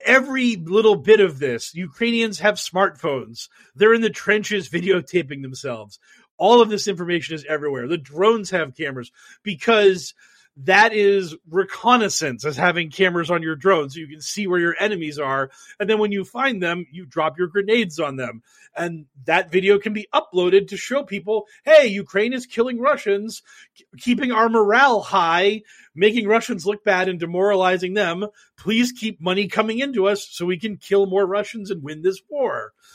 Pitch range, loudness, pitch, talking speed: 170-220 Hz, -20 LUFS, 195 Hz, 175 wpm